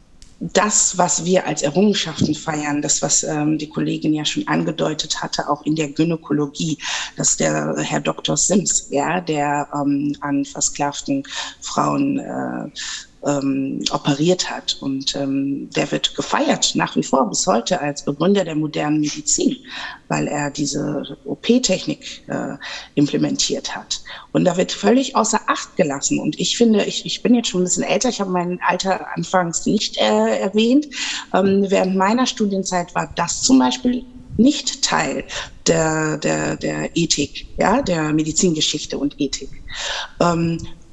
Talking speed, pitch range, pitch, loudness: 150 wpm, 145-195 Hz, 155 Hz, -19 LUFS